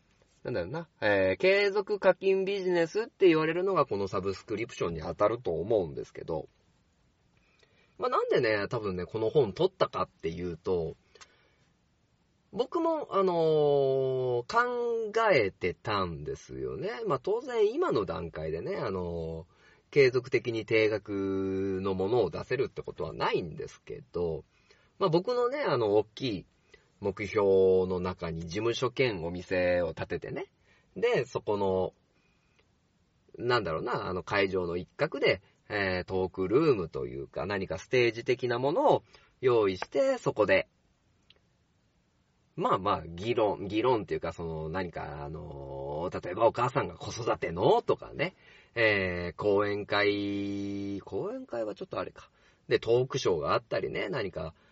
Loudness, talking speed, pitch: -30 LUFS, 280 characters per minute, 110 Hz